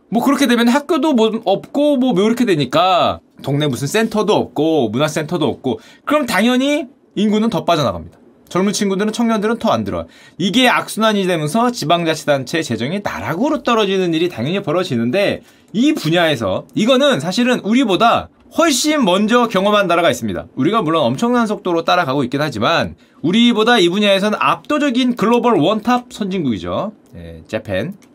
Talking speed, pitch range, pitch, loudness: 375 characters per minute, 175-250 Hz, 215 Hz, -16 LUFS